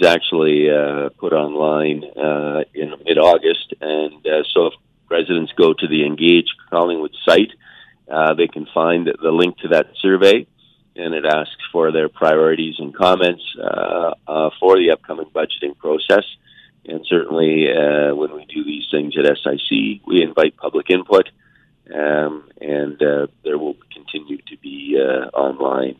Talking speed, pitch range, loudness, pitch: 155 wpm, 75-85 Hz, -17 LUFS, 75 Hz